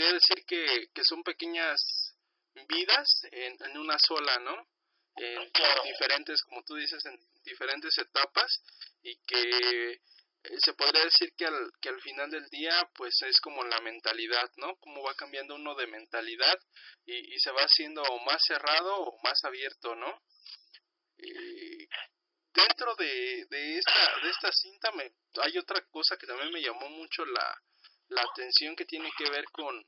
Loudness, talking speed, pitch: -28 LUFS, 160 wpm, 340 Hz